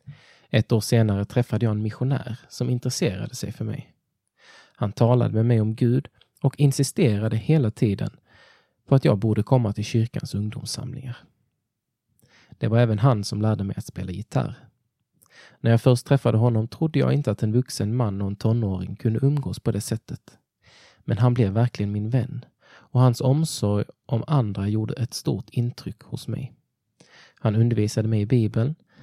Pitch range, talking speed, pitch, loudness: 110-130 Hz, 170 wpm, 120 Hz, -23 LUFS